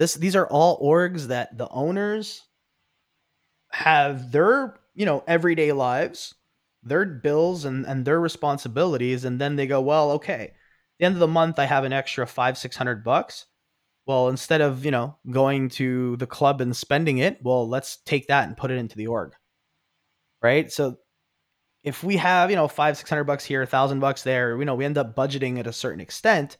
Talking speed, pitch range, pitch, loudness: 200 wpm, 130-160 Hz, 140 Hz, -23 LUFS